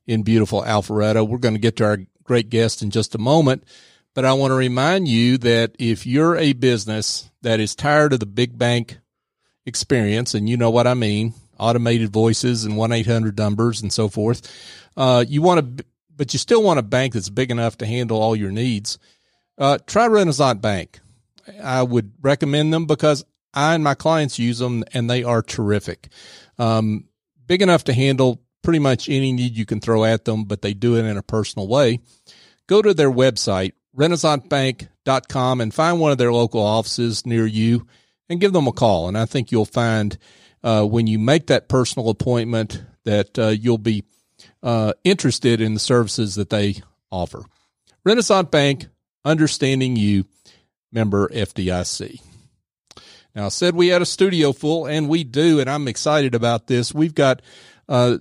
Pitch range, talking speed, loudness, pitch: 110-140 Hz, 180 wpm, -19 LUFS, 120 Hz